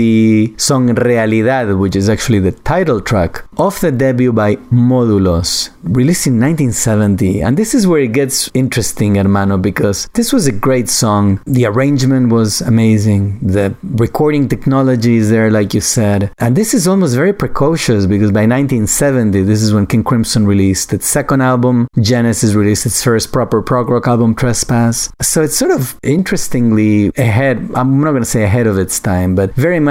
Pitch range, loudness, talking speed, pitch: 105-130 Hz, -12 LUFS, 175 wpm, 120 Hz